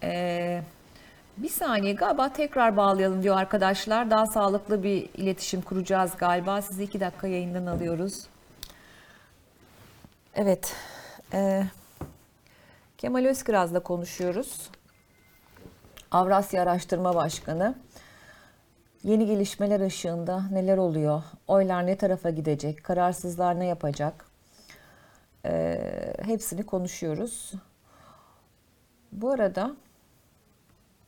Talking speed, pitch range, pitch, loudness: 85 wpm, 175-200 Hz, 190 Hz, -27 LUFS